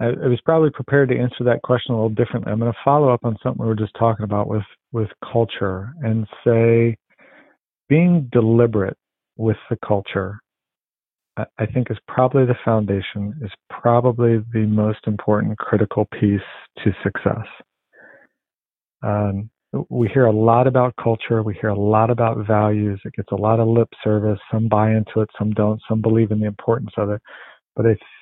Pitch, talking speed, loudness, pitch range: 110 Hz, 180 wpm, -19 LUFS, 105-120 Hz